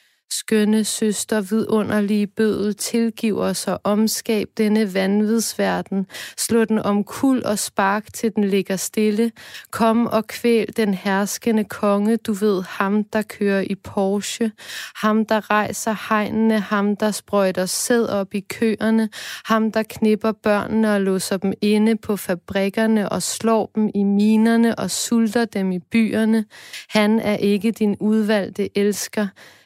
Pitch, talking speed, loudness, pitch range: 215 Hz, 140 wpm, -20 LUFS, 200-220 Hz